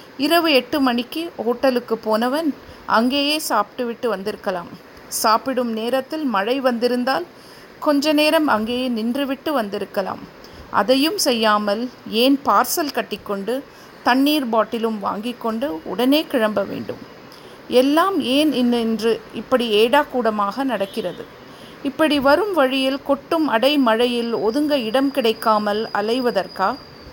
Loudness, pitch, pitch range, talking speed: -19 LUFS, 250 Hz, 225-280 Hz, 95 wpm